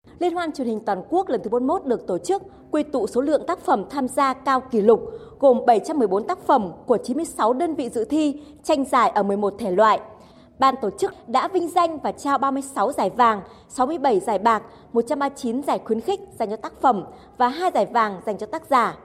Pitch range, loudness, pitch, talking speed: 225-325 Hz, -22 LUFS, 265 Hz, 215 wpm